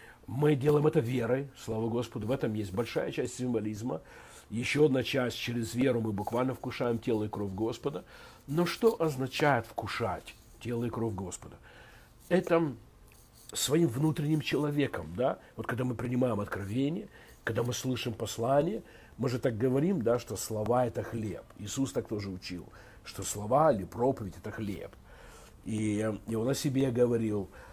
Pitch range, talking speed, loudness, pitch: 110-135 Hz, 150 wpm, -31 LUFS, 120 Hz